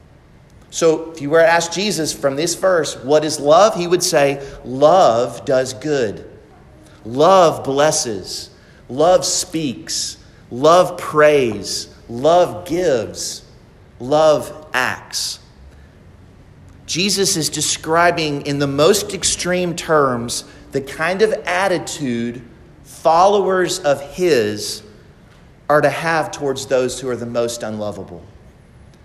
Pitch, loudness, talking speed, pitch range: 150 Hz, -17 LUFS, 110 wpm, 130-170 Hz